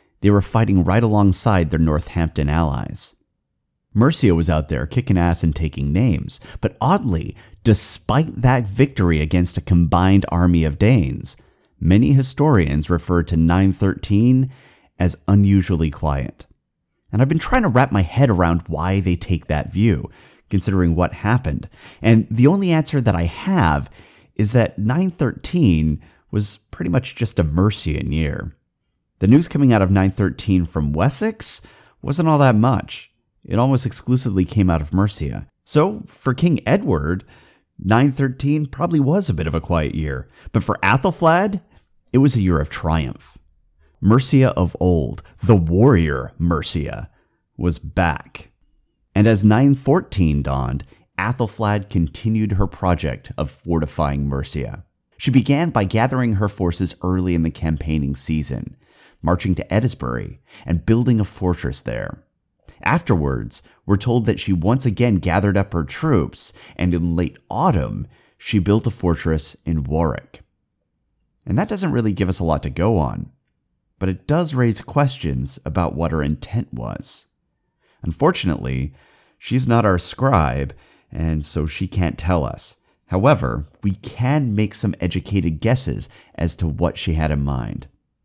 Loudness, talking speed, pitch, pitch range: -19 LUFS, 145 wpm, 95 Hz, 80-115 Hz